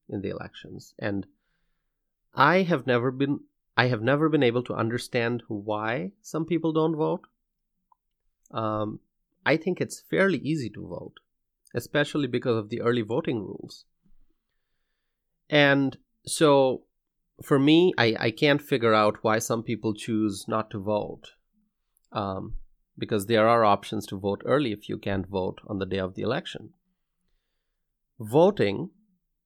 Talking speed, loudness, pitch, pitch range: 145 wpm, -25 LUFS, 120 Hz, 110-155 Hz